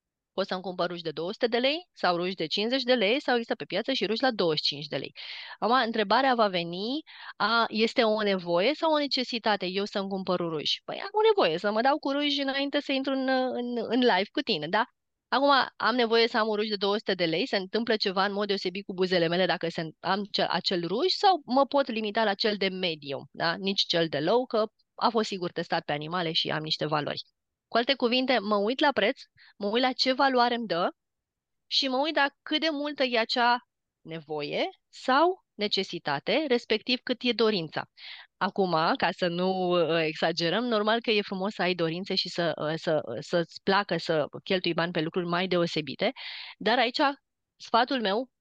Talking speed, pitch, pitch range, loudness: 205 wpm, 210 Hz, 175-250 Hz, -27 LUFS